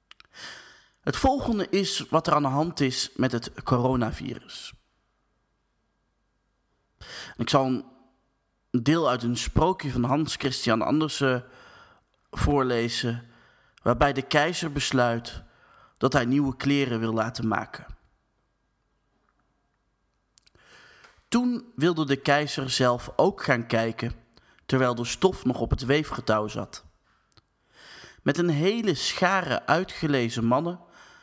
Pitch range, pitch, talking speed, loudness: 120-150 Hz, 130 Hz, 110 wpm, -25 LUFS